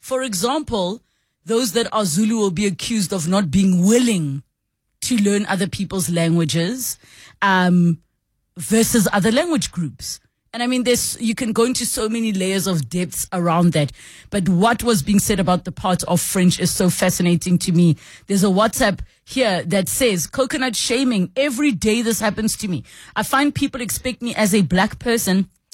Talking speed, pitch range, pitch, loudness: 175 wpm, 180-235 Hz, 200 Hz, -19 LUFS